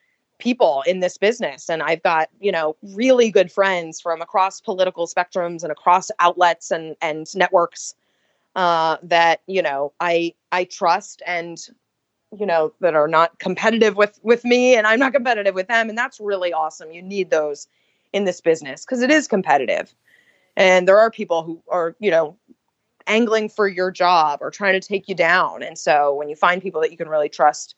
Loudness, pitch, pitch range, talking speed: -19 LUFS, 180 Hz, 165-210 Hz, 190 wpm